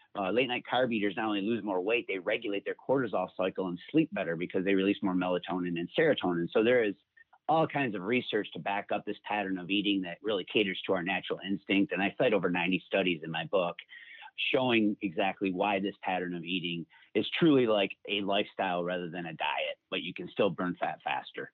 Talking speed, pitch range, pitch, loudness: 215 wpm, 90-105 Hz, 95 Hz, -31 LUFS